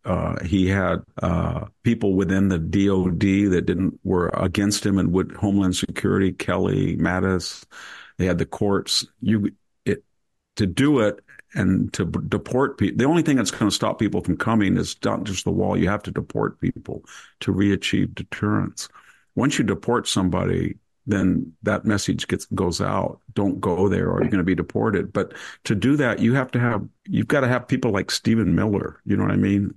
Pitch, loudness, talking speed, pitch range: 100 Hz, -22 LUFS, 190 wpm, 95-115 Hz